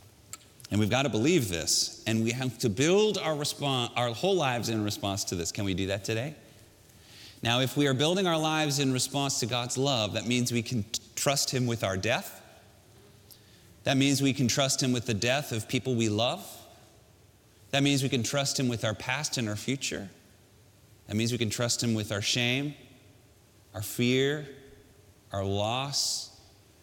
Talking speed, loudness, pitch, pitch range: 190 wpm, -28 LUFS, 120 Hz, 105-135 Hz